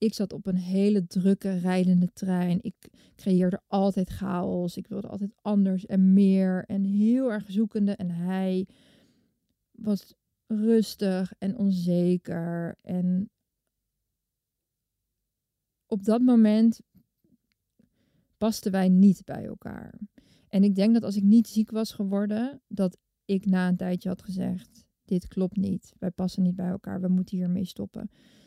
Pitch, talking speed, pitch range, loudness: 195 Hz, 140 wpm, 185-215 Hz, -26 LUFS